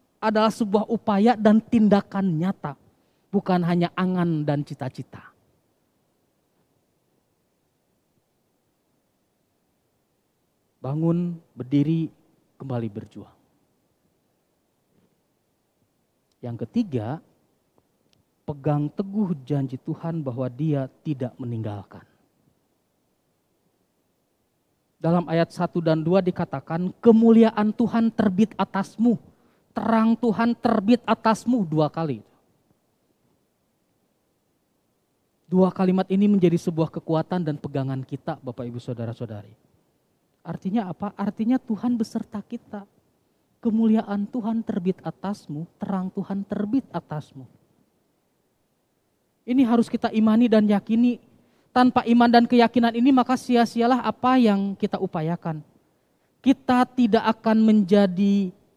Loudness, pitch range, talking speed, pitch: -23 LUFS, 155-225 Hz, 90 wpm, 195 Hz